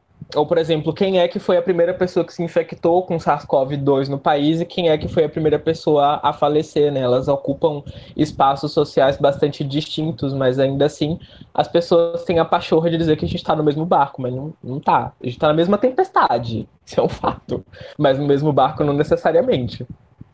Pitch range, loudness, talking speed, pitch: 140-170 Hz, -18 LUFS, 210 wpm, 155 Hz